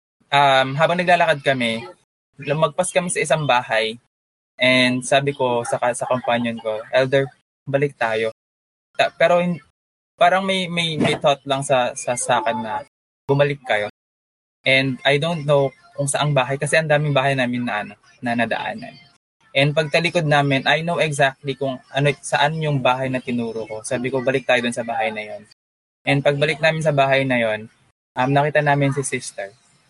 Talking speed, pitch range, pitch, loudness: 175 wpm, 120-145 Hz, 135 Hz, -19 LUFS